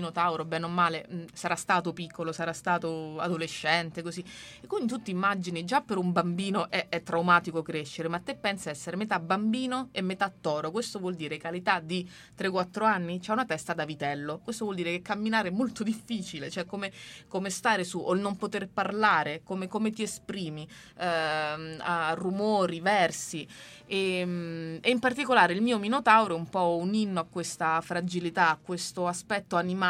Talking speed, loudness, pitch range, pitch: 180 wpm, -29 LUFS, 165-205 Hz, 180 Hz